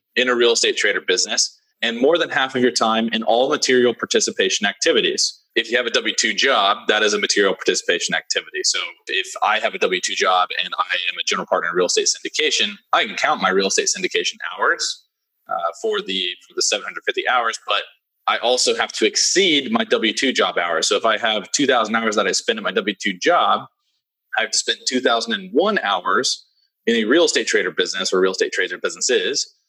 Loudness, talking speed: -18 LUFS, 220 wpm